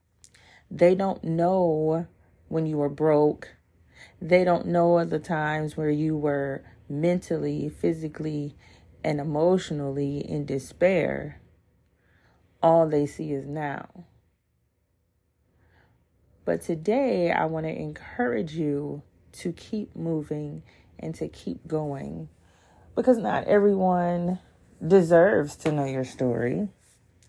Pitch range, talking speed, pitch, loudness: 110-170 Hz, 105 wpm, 150 Hz, -25 LUFS